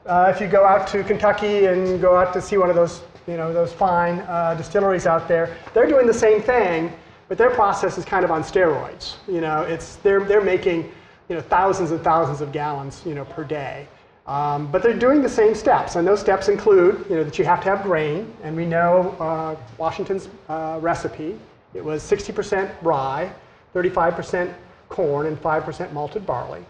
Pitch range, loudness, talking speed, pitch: 160-195 Hz, -20 LUFS, 200 wpm, 180 Hz